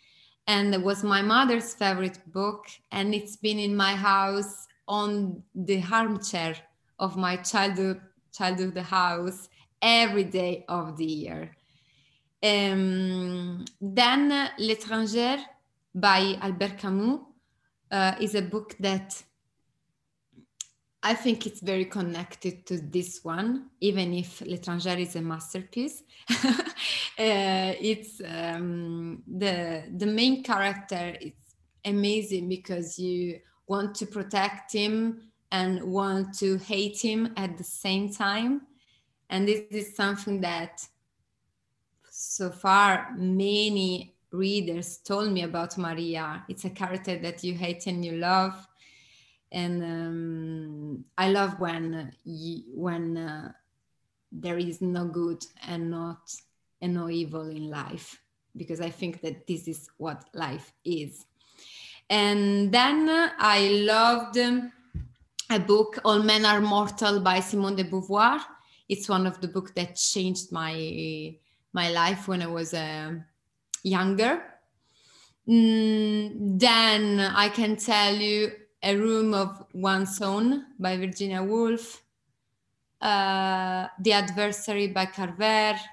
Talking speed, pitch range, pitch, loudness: 120 wpm, 175-210 Hz, 190 Hz, -27 LUFS